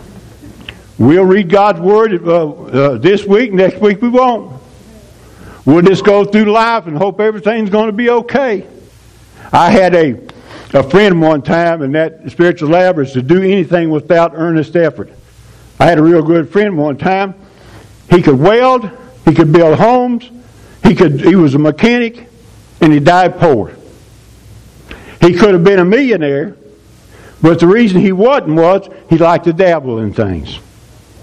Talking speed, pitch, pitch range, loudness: 160 wpm, 170 Hz, 140-200 Hz, -10 LUFS